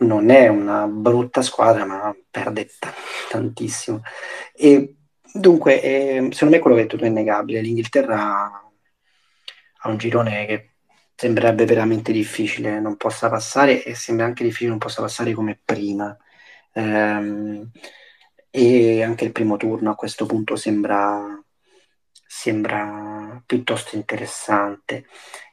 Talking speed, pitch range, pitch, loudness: 120 wpm, 105-120 Hz, 110 Hz, -19 LUFS